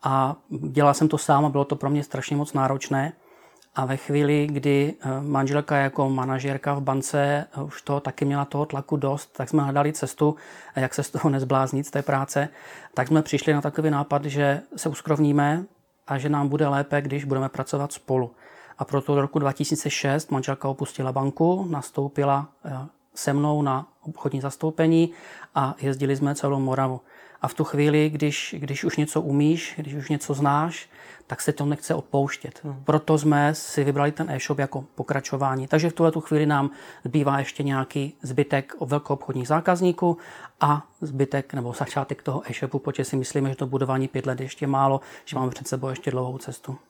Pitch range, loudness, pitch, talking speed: 135-150 Hz, -25 LUFS, 140 Hz, 180 wpm